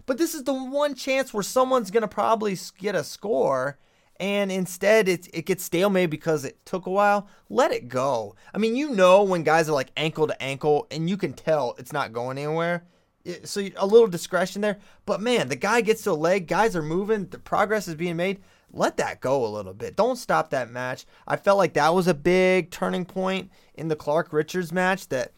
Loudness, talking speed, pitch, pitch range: -24 LUFS, 220 wpm, 185 Hz, 165-210 Hz